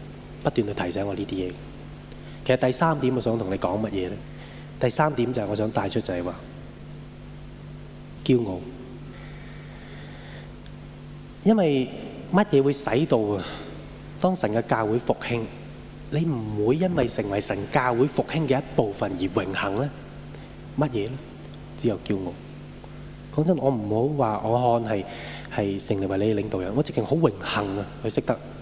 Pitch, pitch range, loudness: 120 Hz, 105-140 Hz, -25 LUFS